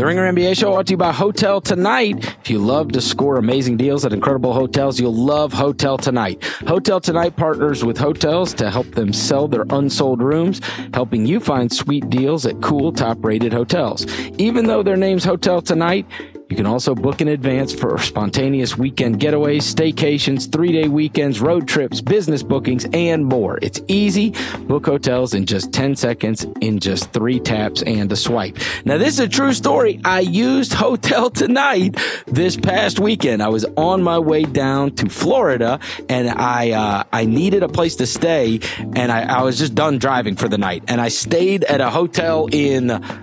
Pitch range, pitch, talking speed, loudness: 120-170 Hz, 140 Hz, 185 wpm, -17 LUFS